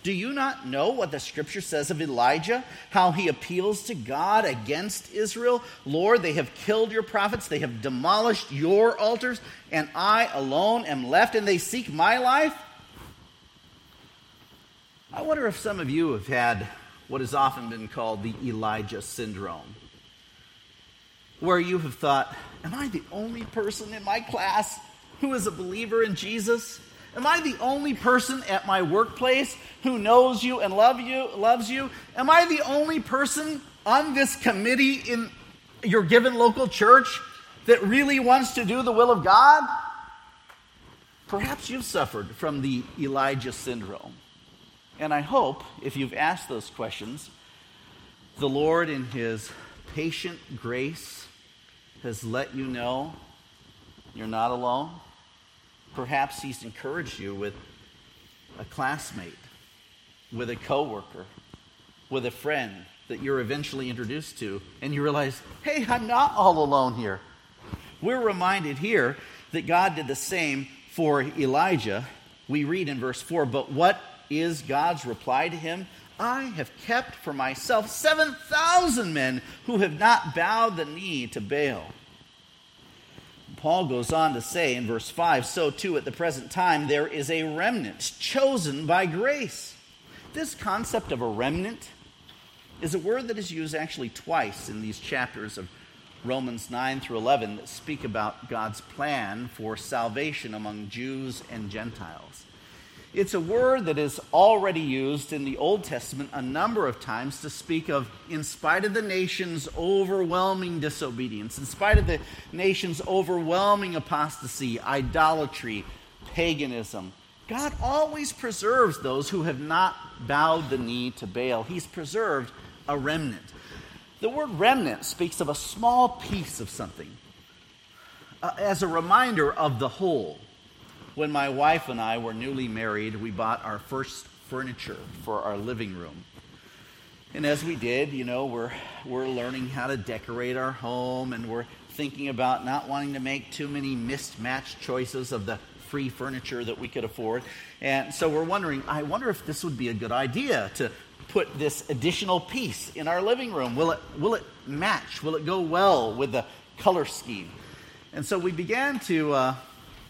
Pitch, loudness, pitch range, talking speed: 150 Hz, -26 LUFS, 130-210 Hz, 155 wpm